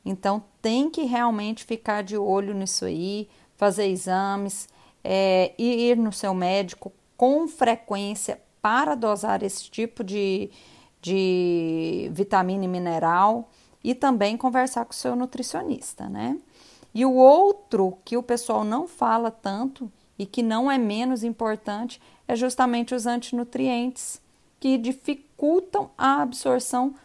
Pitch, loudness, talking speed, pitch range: 230 Hz, -24 LUFS, 130 wpm, 200-255 Hz